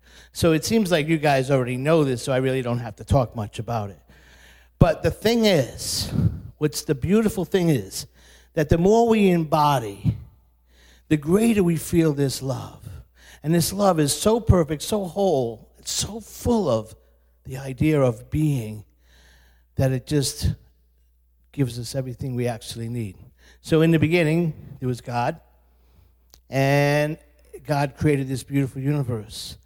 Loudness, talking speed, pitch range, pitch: -22 LUFS, 155 wpm, 100-155 Hz, 130 Hz